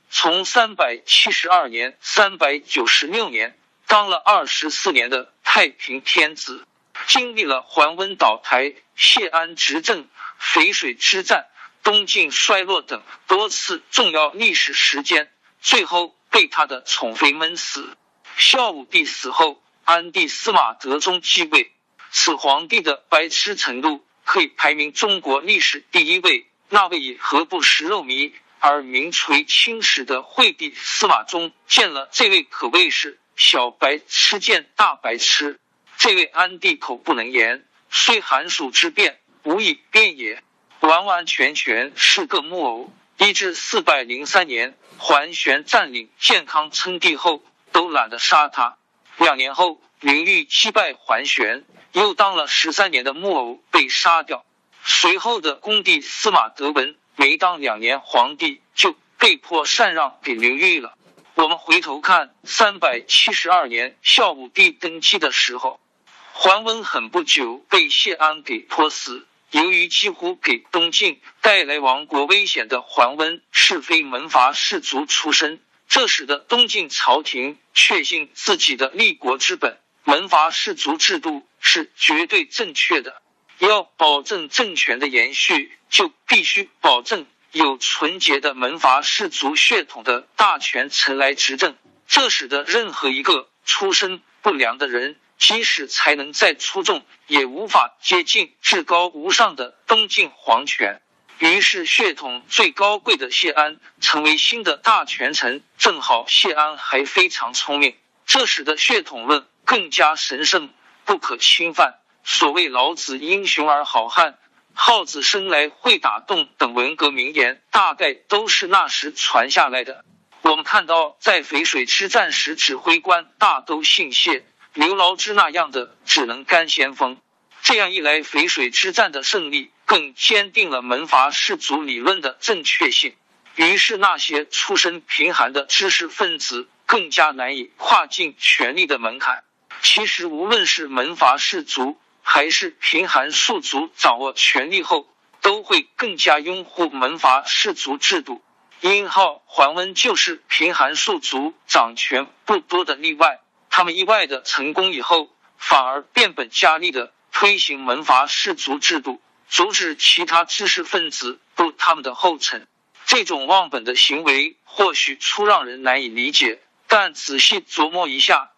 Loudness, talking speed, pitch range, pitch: -17 LUFS, 220 characters per minute, 150-215 Hz, 175 Hz